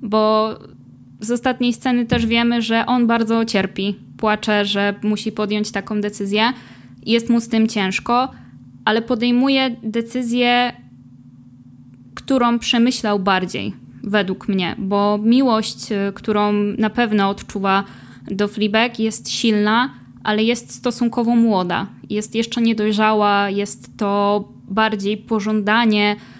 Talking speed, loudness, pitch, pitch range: 115 wpm, -18 LUFS, 215 Hz, 200-235 Hz